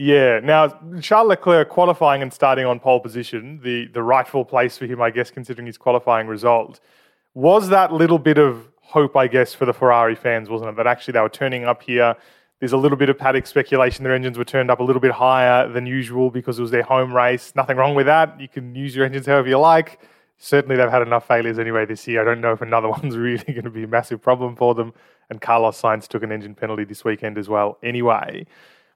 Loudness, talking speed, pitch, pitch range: -18 LUFS, 235 wpm, 125 Hz, 115-135 Hz